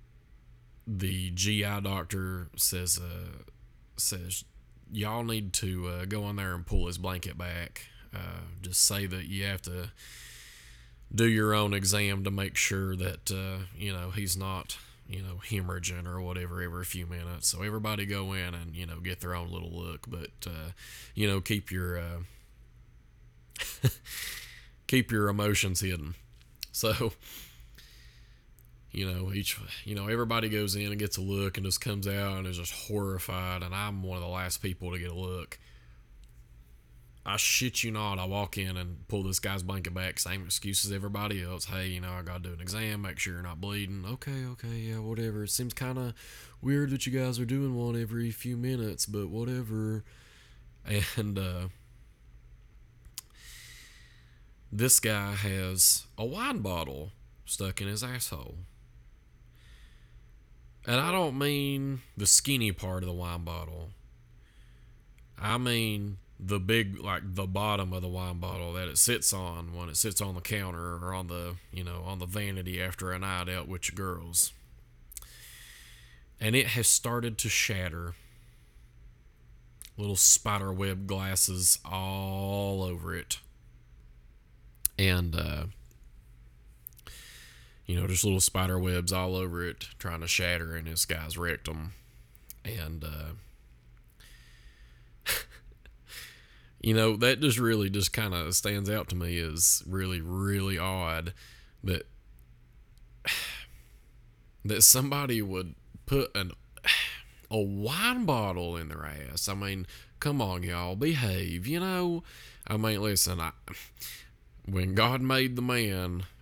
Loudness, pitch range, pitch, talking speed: -30 LUFS, 85-105 Hz, 95 Hz, 150 wpm